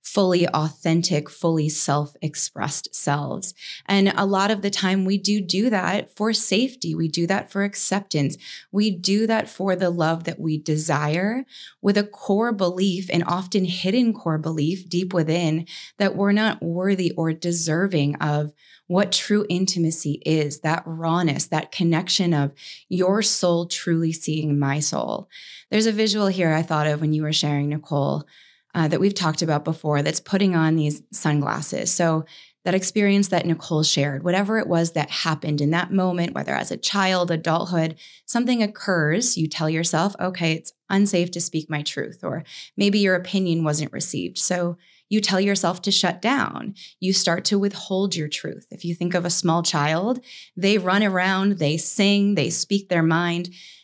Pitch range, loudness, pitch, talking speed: 160-195 Hz, -22 LUFS, 175 Hz, 170 wpm